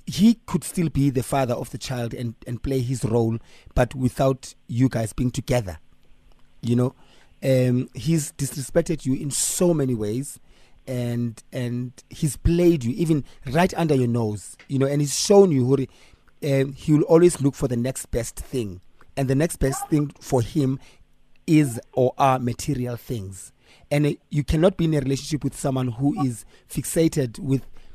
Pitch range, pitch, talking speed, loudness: 120-145 Hz, 130 Hz, 180 wpm, -23 LUFS